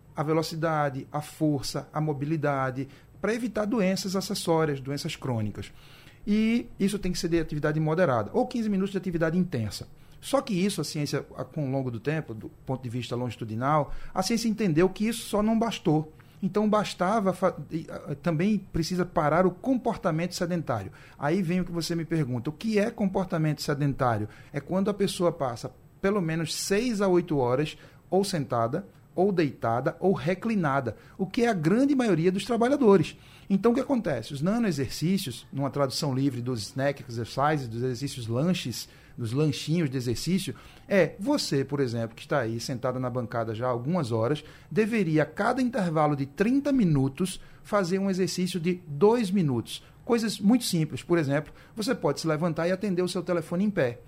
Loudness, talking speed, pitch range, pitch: -27 LUFS, 175 wpm, 140-190 Hz, 160 Hz